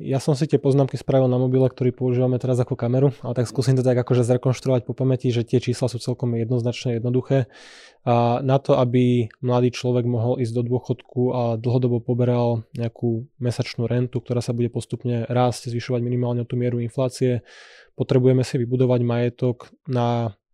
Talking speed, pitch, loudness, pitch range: 180 wpm, 125 Hz, -22 LUFS, 120-130 Hz